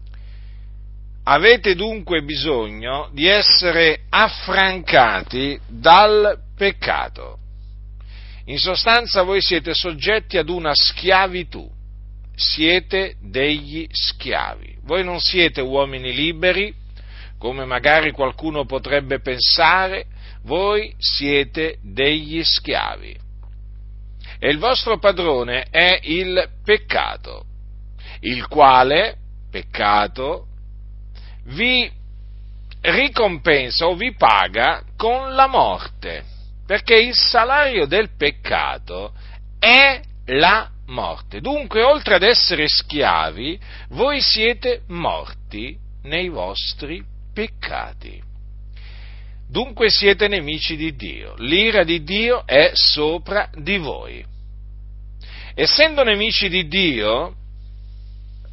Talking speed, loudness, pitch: 90 wpm, -16 LUFS, 140 Hz